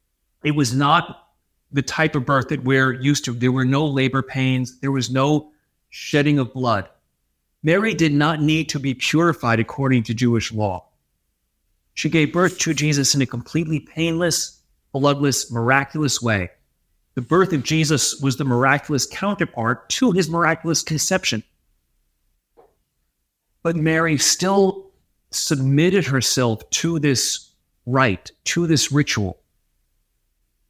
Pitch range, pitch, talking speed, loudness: 115-155 Hz, 135 Hz, 135 wpm, -19 LUFS